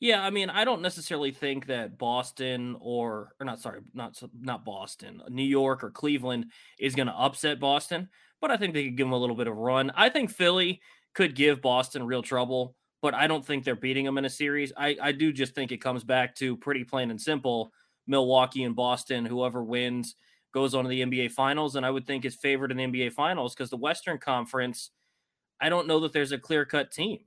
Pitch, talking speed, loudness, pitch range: 135 Hz, 225 wpm, -28 LUFS, 125-150 Hz